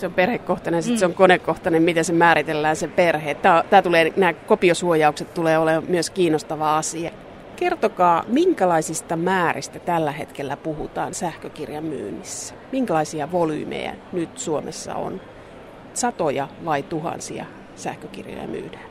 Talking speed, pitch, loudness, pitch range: 125 wpm, 170 Hz, -21 LUFS, 160-180 Hz